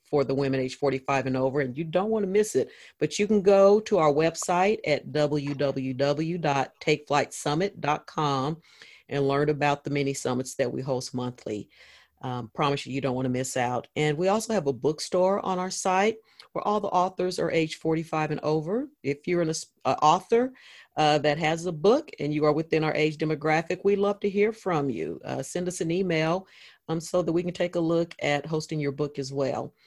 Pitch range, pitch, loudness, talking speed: 140-180 Hz, 155 Hz, -26 LUFS, 205 wpm